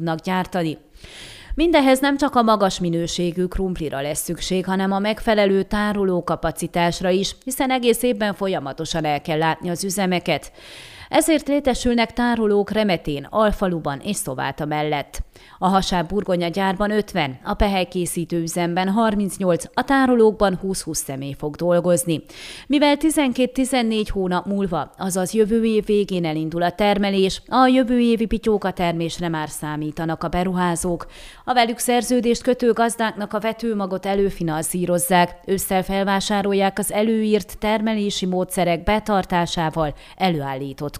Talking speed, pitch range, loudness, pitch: 125 wpm, 170-220 Hz, -20 LUFS, 190 Hz